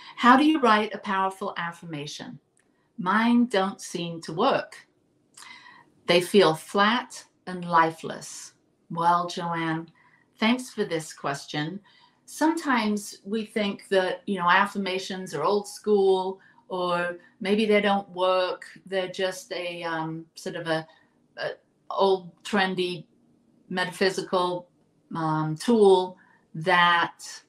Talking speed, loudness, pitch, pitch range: 115 wpm, -25 LUFS, 190 Hz, 175-210 Hz